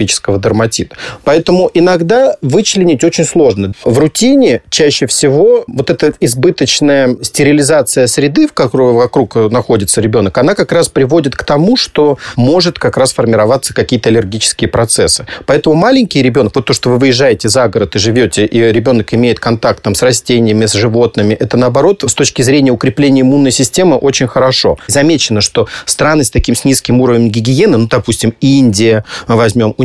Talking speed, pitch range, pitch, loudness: 160 wpm, 115-150 Hz, 130 Hz, -9 LUFS